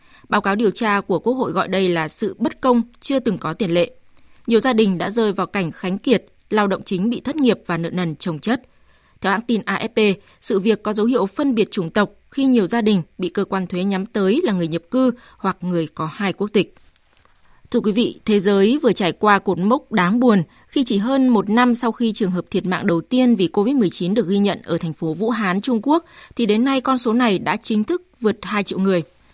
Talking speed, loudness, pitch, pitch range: 250 wpm, -19 LUFS, 205 Hz, 185-235 Hz